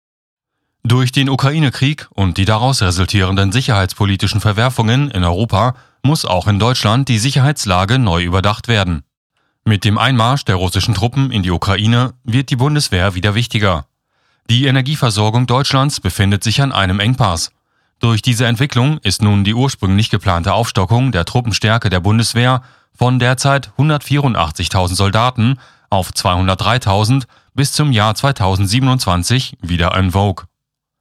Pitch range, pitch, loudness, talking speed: 100-130 Hz, 115 Hz, -14 LUFS, 130 wpm